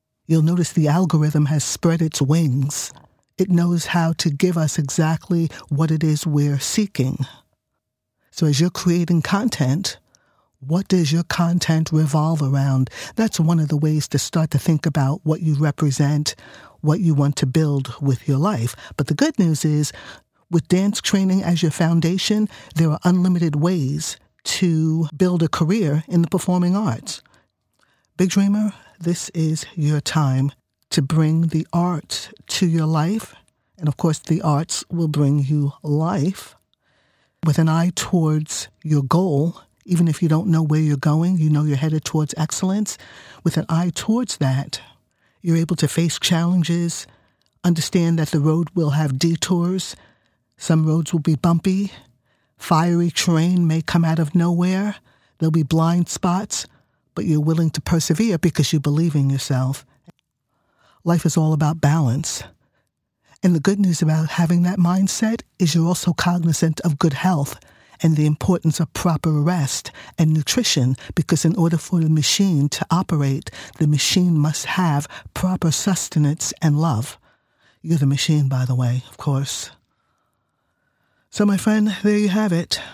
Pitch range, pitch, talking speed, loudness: 150-175 Hz, 160 Hz, 160 wpm, -20 LUFS